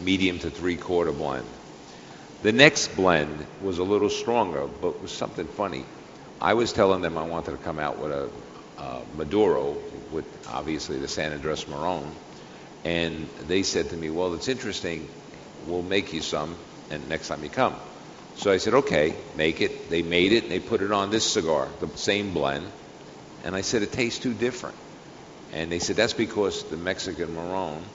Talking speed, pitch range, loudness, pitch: 185 wpm, 80-100 Hz, -26 LUFS, 90 Hz